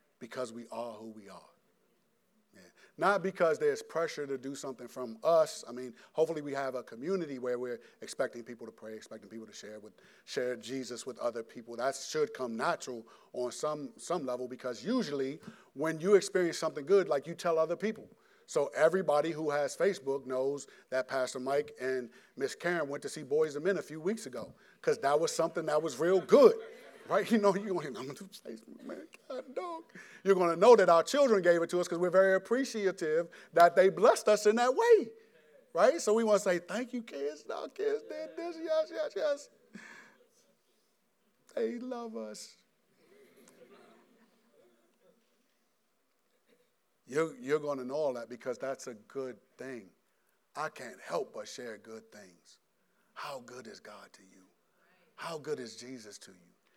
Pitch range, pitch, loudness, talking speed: 130-215 Hz, 165 Hz, -31 LUFS, 175 wpm